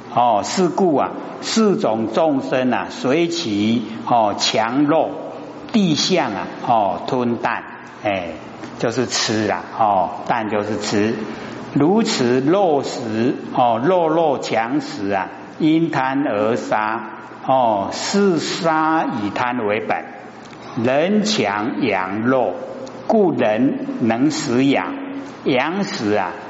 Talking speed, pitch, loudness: 145 characters per minute, 160 Hz, -19 LUFS